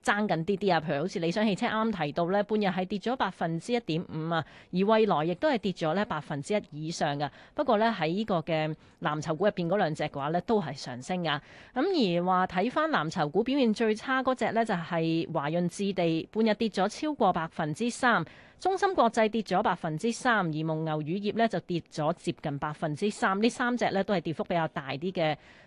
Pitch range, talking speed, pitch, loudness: 160-220 Hz, 325 characters per minute, 185 Hz, -29 LUFS